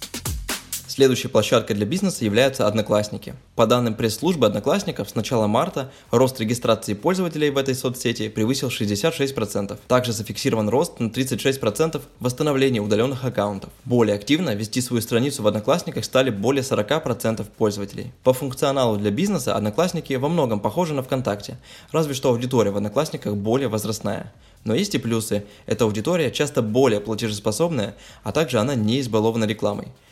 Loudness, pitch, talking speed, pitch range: -22 LUFS, 120 Hz, 145 wpm, 110-135 Hz